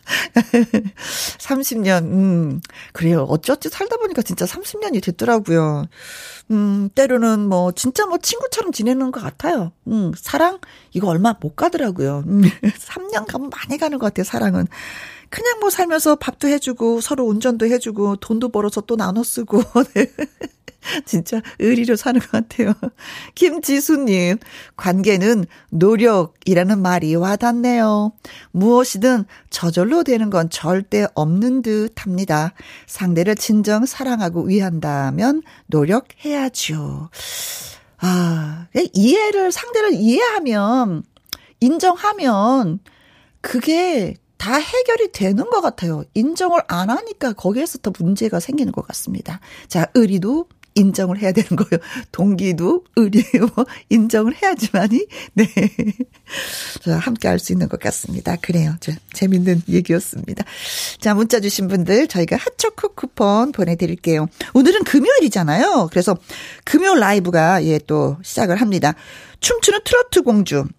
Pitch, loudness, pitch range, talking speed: 220 Hz, -18 LUFS, 185-265 Hz, 275 characters per minute